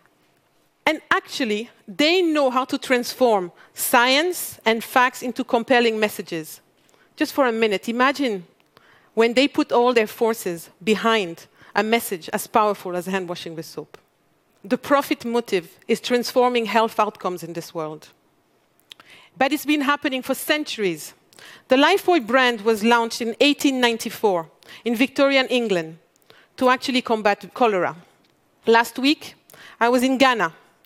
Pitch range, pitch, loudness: 210-265 Hz, 235 Hz, -21 LUFS